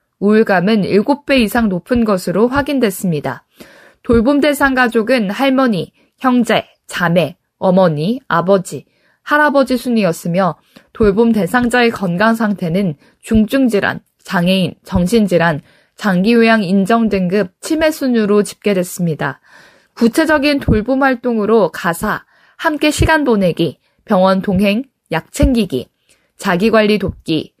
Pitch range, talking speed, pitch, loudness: 185-250 Hz, 265 characters per minute, 215 Hz, -14 LUFS